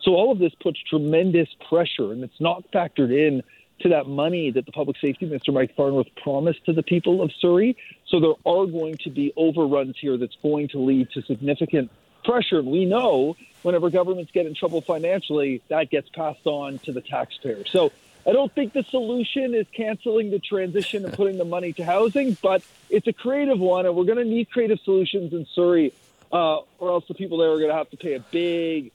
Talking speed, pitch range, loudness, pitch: 215 wpm, 150-190 Hz, -23 LUFS, 170 Hz